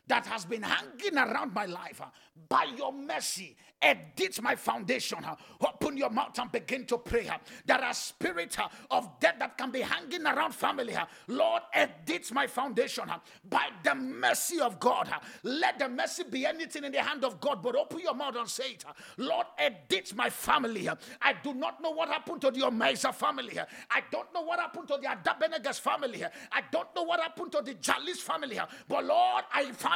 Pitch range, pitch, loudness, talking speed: 265-345 Hz, 300 Hz, -31 LUFS, 210 wpm